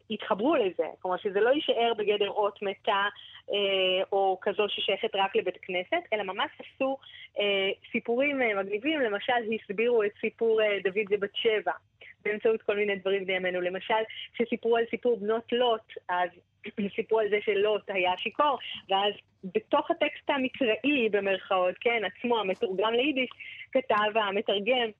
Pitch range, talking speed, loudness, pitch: 200-240 Hz, 145 wpm, -28 LUFS, 215 Hz